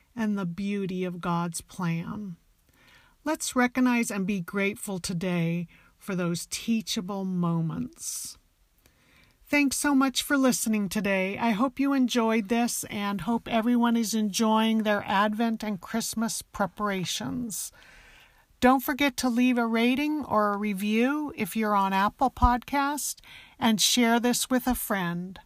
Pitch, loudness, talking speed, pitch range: 220 Hz, -27 LUFS, 135 wpm, 200-245 Hz